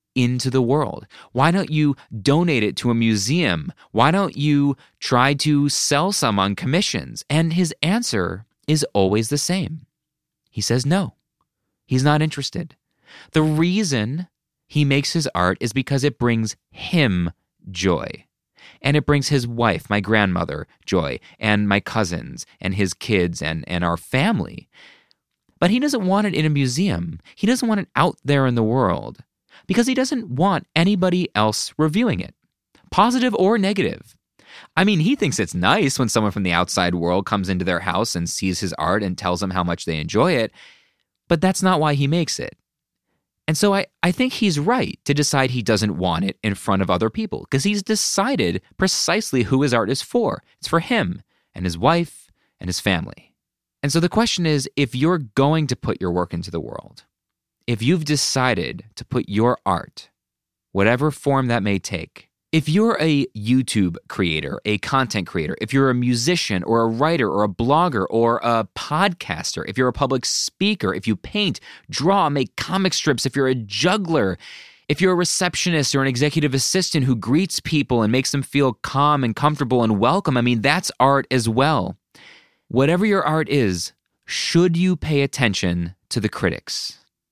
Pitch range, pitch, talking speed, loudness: 105-160 Hz, 135 Hz, 180 wpm, -20 LUFS